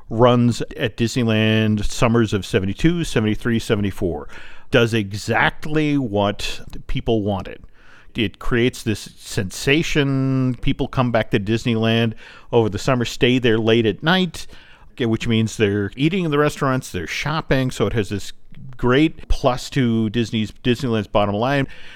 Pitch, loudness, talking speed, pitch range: 120 Hz, -20 LUFS, 140 wpm, 110-135 Hz